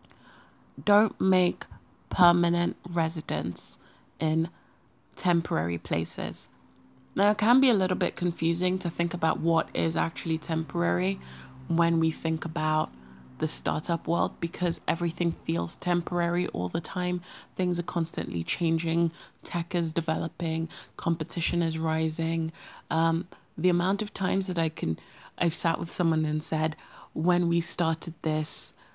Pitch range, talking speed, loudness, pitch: 160-175 Hz, 135 wpm, -28 LUFS, 165 Hz